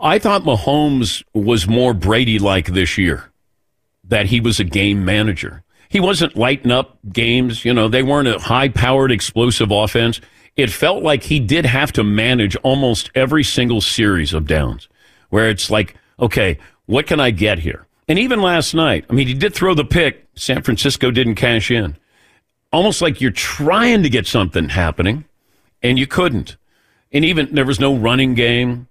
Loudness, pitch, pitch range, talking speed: -15 LUFS, 120 Hz, 105-135 Hz, 180 wpm